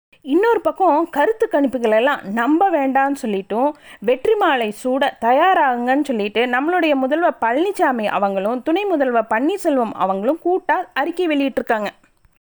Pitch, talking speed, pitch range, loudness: 275 Hz, 105 wpm, 235-335 Hz, -18 LUFS